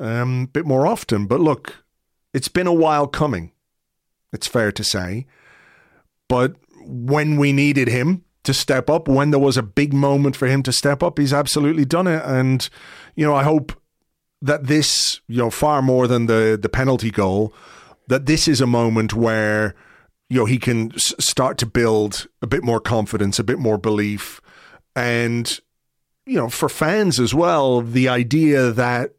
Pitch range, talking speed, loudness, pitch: 115-145 Hz, 180 wpm, -18 LUFS, 130 Hz